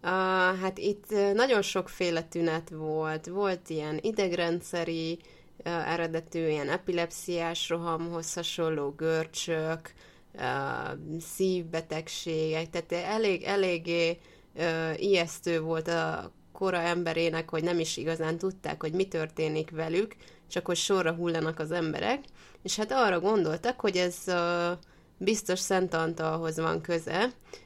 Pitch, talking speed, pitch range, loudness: 170 Hz, 120 wpm, 160-185 Hz, -30 LUFS